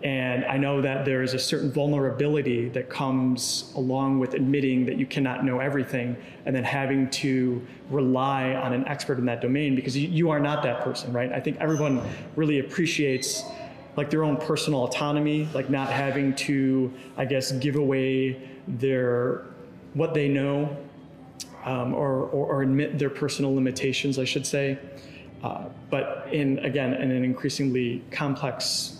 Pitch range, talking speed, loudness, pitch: 130-145 Hz, 160 wpm, -26 LUFS, 135 Hz